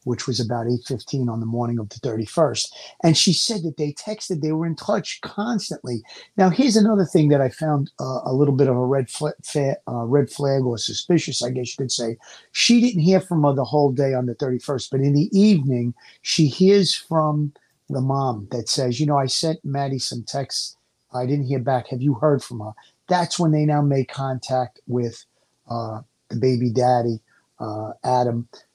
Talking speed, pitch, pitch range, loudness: 205 wpm, 135 Hz, 125-155 Hz, -21 LUFS